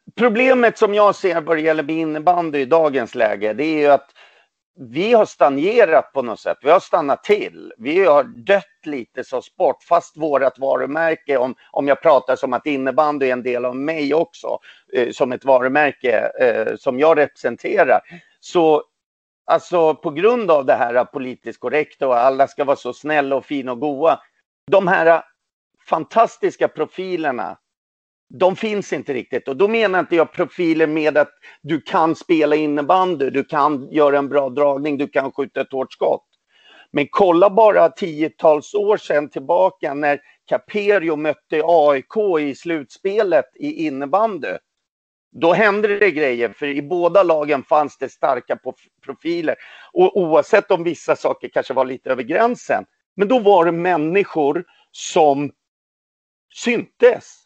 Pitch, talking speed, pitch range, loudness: 160 Hz, 155 wpm, 145-200 Hz, -18 LUFS